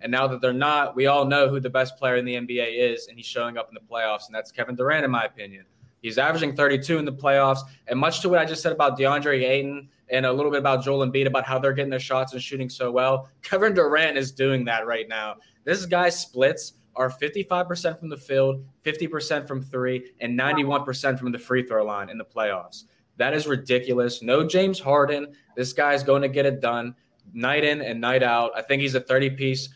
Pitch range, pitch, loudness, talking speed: 125-145 Hz, 135 Hz, -23 LUFS, 230 wpm